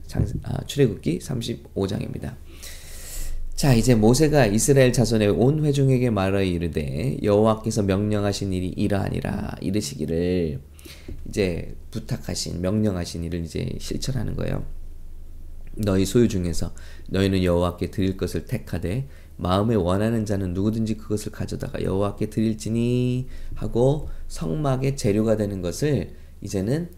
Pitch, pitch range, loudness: 95 Hz, 80-110 Hz, -23 LUFS